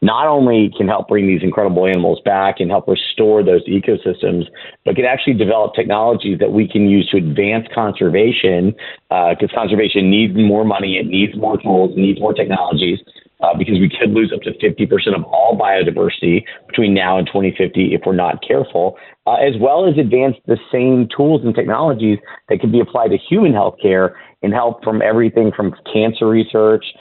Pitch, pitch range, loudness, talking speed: 105 Hz, 95-115 Hz, -15 LUFS, 185 wpm